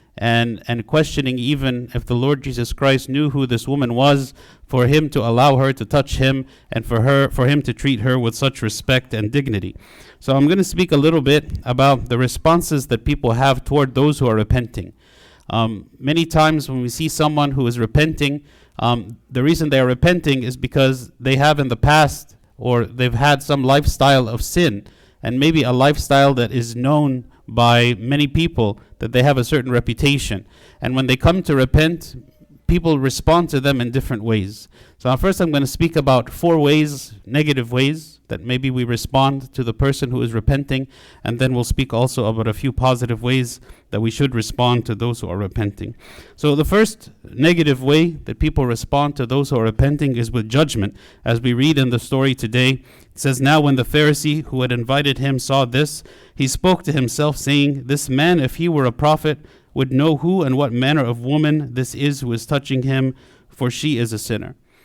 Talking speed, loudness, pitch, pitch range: 205 wpm, -18 LUFS, 135 Hz, 120-145 Hz